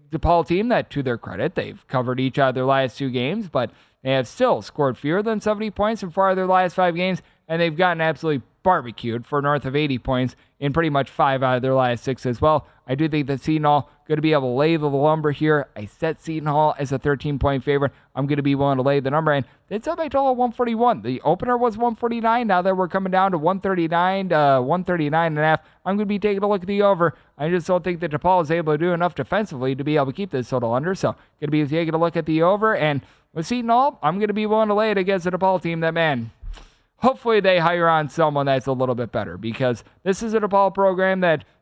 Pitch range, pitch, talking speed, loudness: 140-190 Hz, 160 Hz, 250 wpm, -21 LUFS